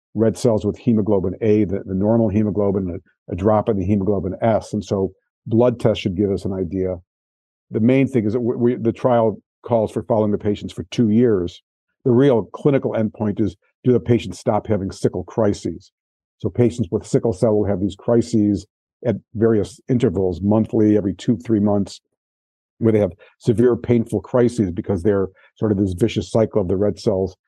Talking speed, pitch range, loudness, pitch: 190 wpm, 100-115 Hz, -20 LUFS, 105 Hz